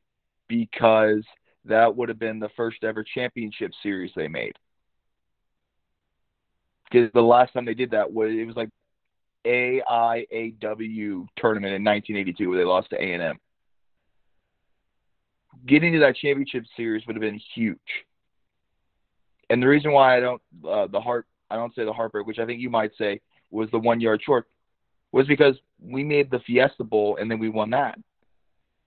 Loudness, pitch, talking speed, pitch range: -23 LUFS, 115 Hz, 165 wpm, 110-125 Hz